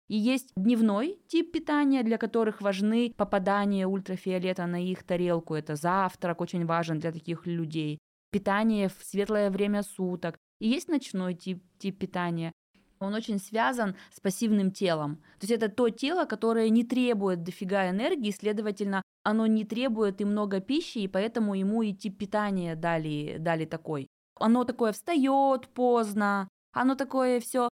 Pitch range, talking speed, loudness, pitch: 185-230 Hz, 150 wpm, -29 LUFS, 205 Hz